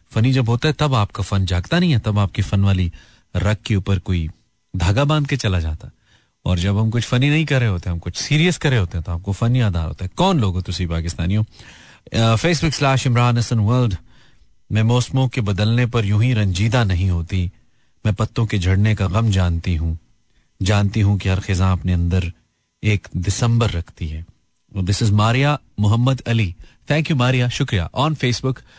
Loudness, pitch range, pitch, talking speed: -19 LUFS, 95-125 Hz, 105 Hz, 195 wpm